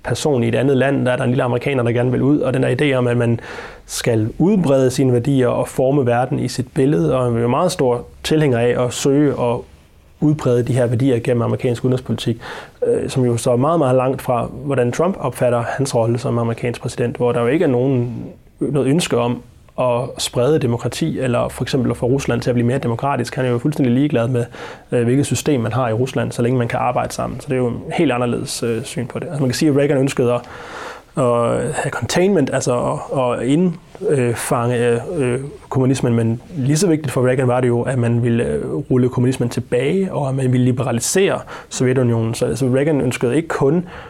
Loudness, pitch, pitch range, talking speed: -18 LUFS, 125 Hz, 120-135 Hz, 215 wpm